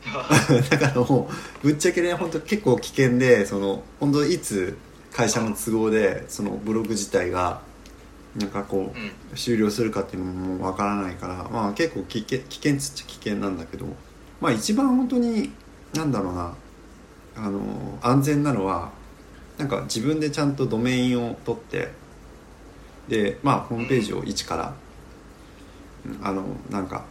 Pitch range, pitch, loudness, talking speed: 95-140 Hz, 110 Hz, -24 LUFS, 295 characters per minute